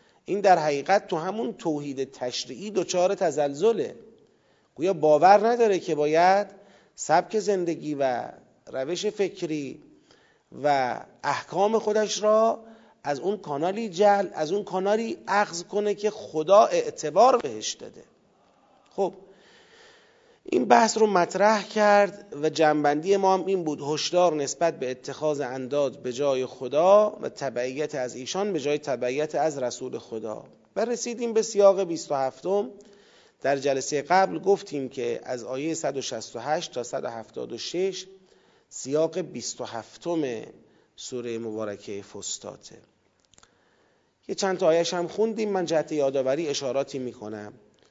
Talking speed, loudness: 125 wpm, -25 LUFS